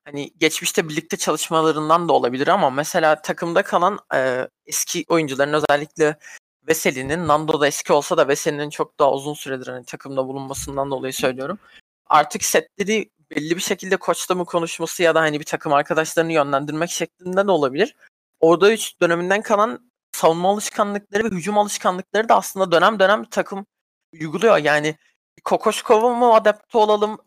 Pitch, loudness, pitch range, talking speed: 170 Hz, -19 LUFS, 150-200 Hz, 150 wpm